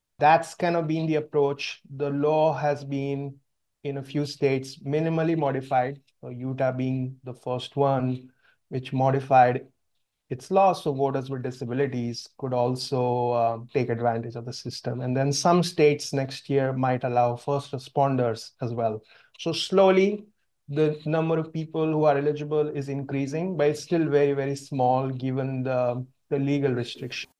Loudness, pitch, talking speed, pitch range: -26 LUFS, 140 Hz, 155 wpm, 130-150 Hz